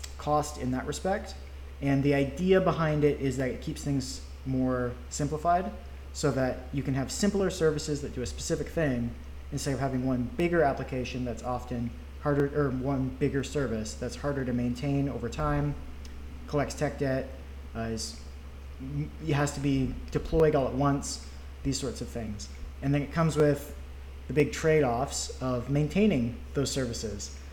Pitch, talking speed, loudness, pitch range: 130 Hz, 170 wpm, -30 LUFS, 90-145 Hz